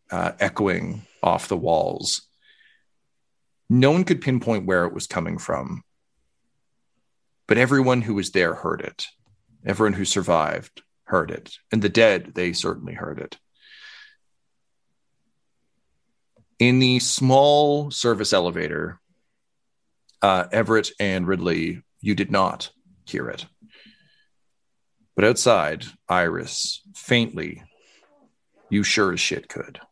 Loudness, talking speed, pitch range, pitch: -22 LUFS, 110 wpm, 100-150 Hz, 120 Hz